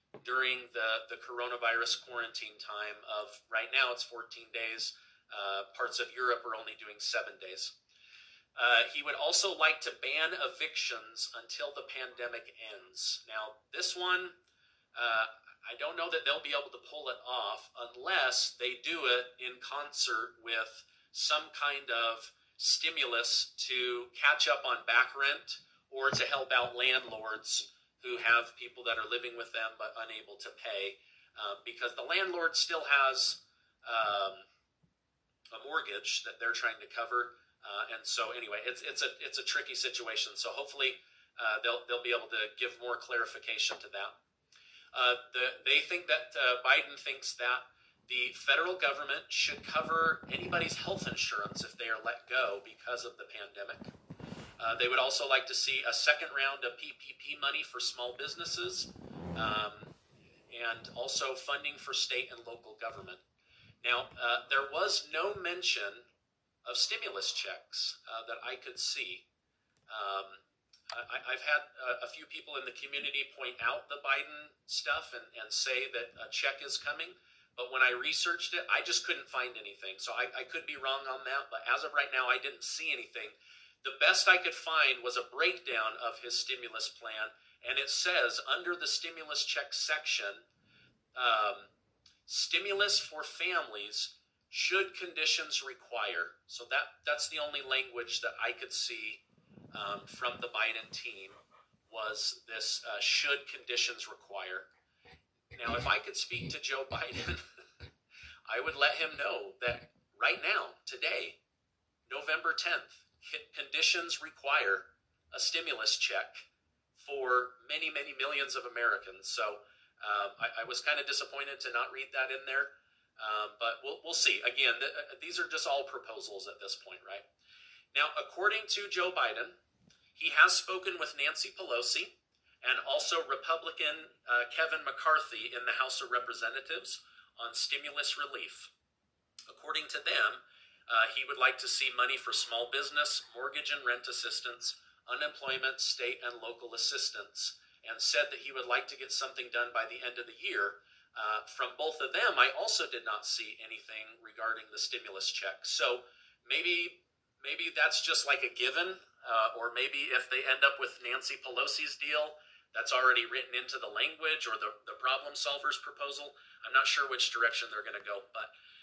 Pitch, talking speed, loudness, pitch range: 140 Hz, 165 wpm, -33 LUFS, 120-195 Hz